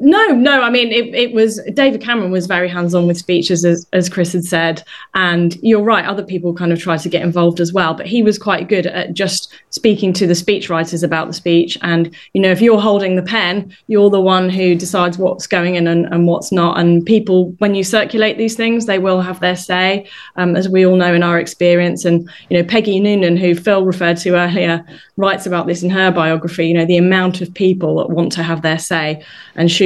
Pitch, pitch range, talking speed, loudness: 180 Hz, 170-200 Hz, 235 wpm, -14 LUFS